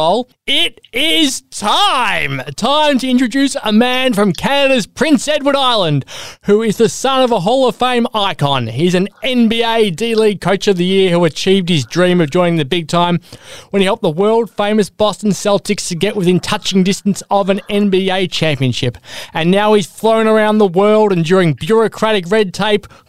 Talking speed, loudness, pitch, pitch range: 180 wpm, -13 LUFS, 205 Hz, 180-225 Hz